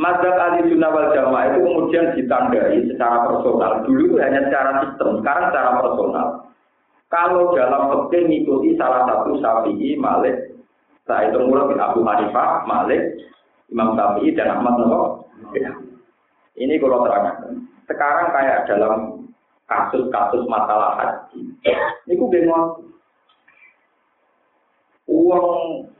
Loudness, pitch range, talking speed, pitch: -18 LUFS, 170-255 Hz, 115 wpm, 175 Hz